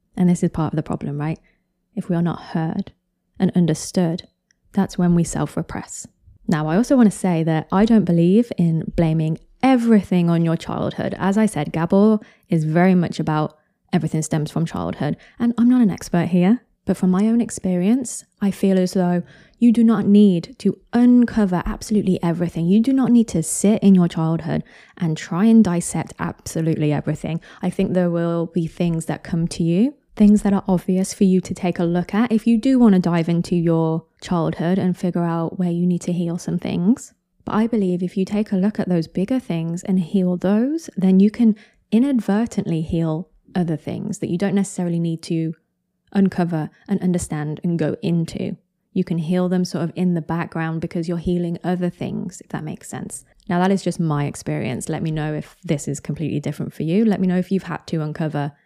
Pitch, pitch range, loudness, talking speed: 180 Hz, 165-200 Hz, -20 LUFS, 205 wpm